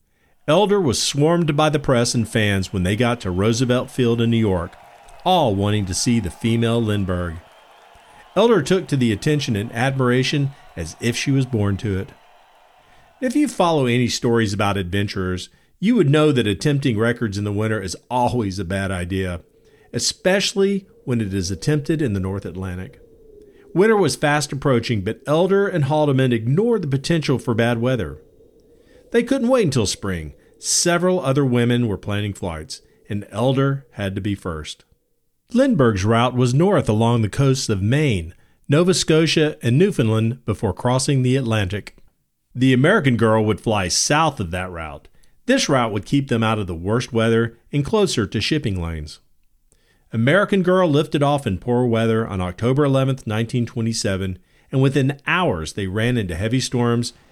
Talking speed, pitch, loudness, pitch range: 165 wpm, 120 Hz, -19 LUFS, 100-145 Hz